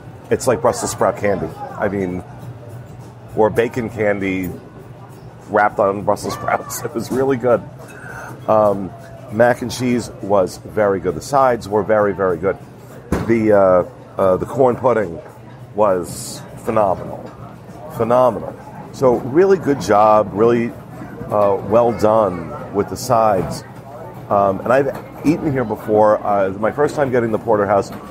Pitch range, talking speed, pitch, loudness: 100-125 Hz, 135 wpm, 110 Hz, -17 LUFS